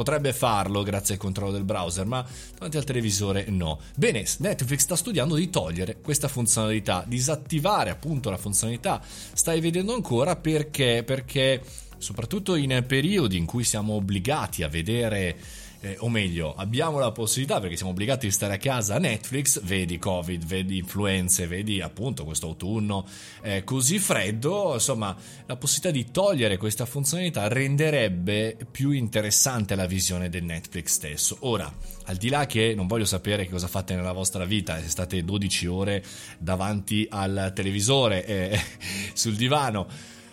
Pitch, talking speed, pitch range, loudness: 105 Hz, 150 wpm, 95-135 Hz, -25 LUFS